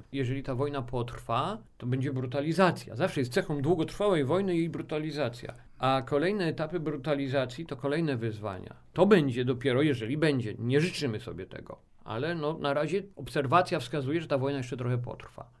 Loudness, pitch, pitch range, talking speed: -30 LUFS, 145 Hz, 130-160 Hz, 160 wpm